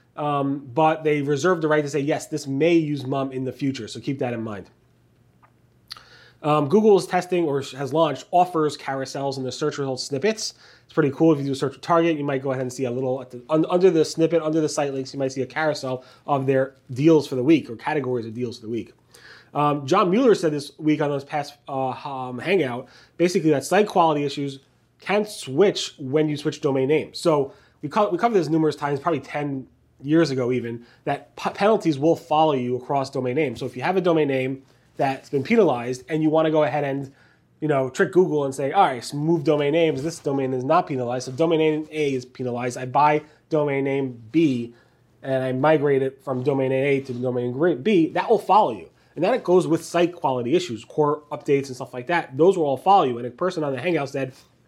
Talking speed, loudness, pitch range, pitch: 235 wpm, -22 LUFS, 130-160 Hz, 145 Hz